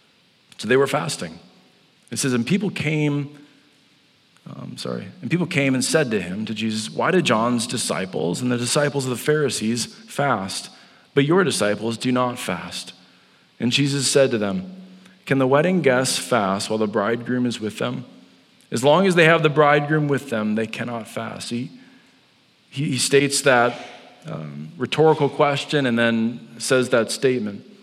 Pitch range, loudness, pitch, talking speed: 115-150 Hz, -21 LUFS, 135 Hz, 170 wpm